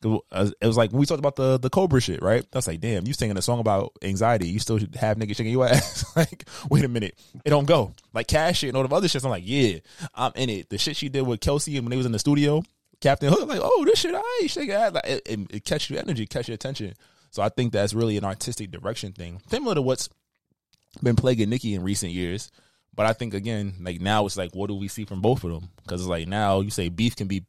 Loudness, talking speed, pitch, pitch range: -24 LUFS, 265 wpm, 115 Hz, 100-140 Hz